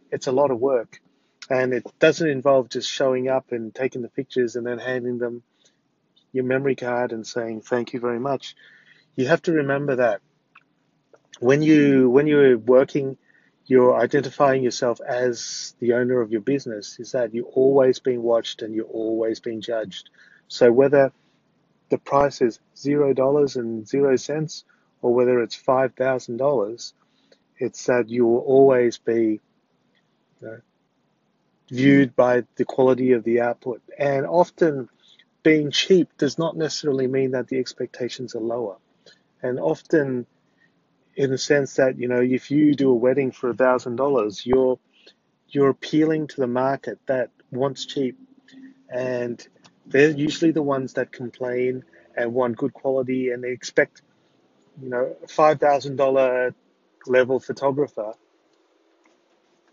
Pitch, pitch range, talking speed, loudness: 130 Hz, 125-140 Hz, 145 wpm, -21 LUFS